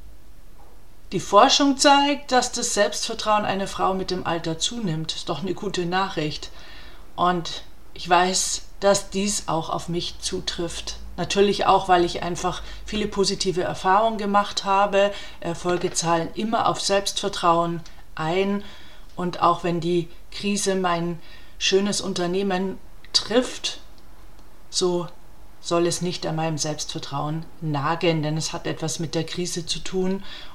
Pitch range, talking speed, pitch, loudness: 170-200 Hz, 135 wpm, 180 Hz, -23 LUFS